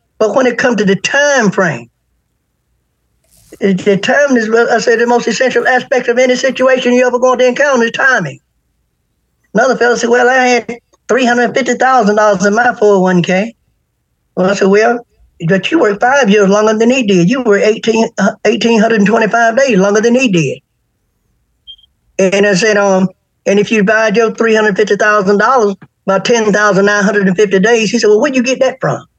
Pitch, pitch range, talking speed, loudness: 220 Hz, 200-245 Hz, 165 wpm, -10 LUFS